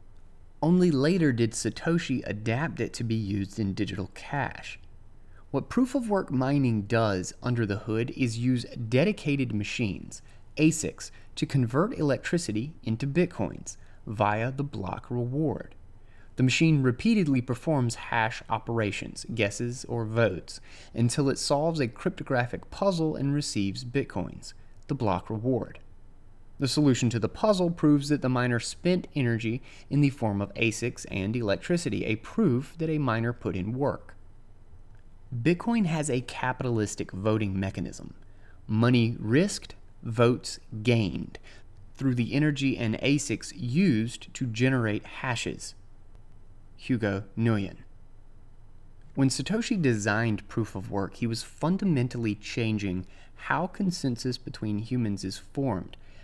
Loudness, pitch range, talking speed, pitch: -28 LUFS, 100-140 Hz, 125 wpm, 115 Hz